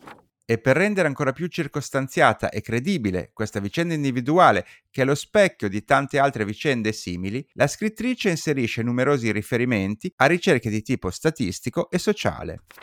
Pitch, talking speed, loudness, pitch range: 135 Hz, 150 wpm, -23 LUFS, 110-165 Hz